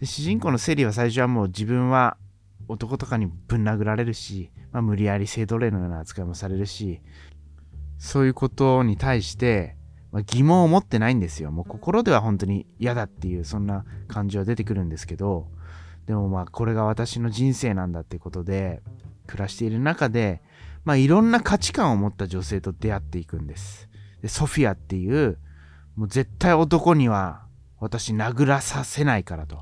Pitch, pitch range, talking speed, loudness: 105 Hz, 95-125 Hz, 365 characters per minute, -23 LUFS